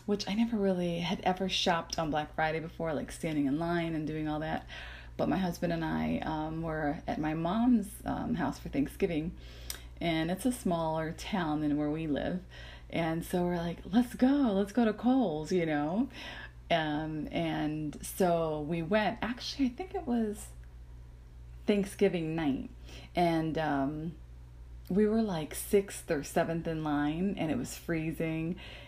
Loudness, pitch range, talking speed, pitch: -32 LUFS, 150-195 Hz, 165 wpm, 165 Hz